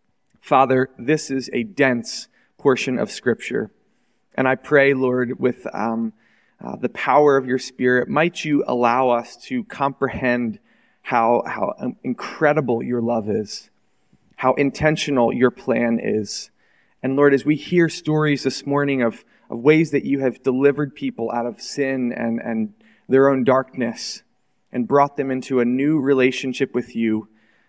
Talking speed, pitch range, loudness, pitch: 150 wpm, 120-140 Hz, -20 LUFS, 130 Hz